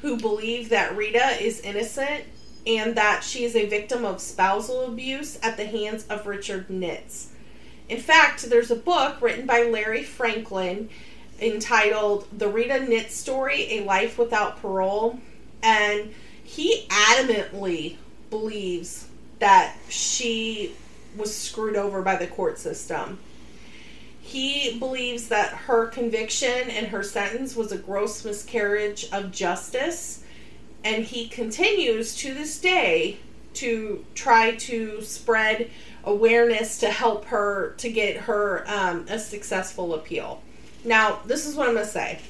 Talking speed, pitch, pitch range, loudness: 135 wpm, 225 Hz, 210-240 Hz, -24 LUFS